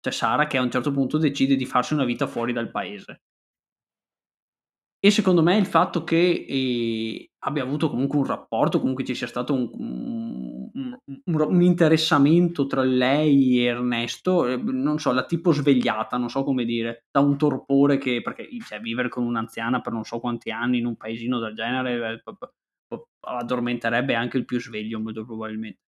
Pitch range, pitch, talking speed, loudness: 120-150 Hz, 130 Hz, 175 wpm, -23 LUFS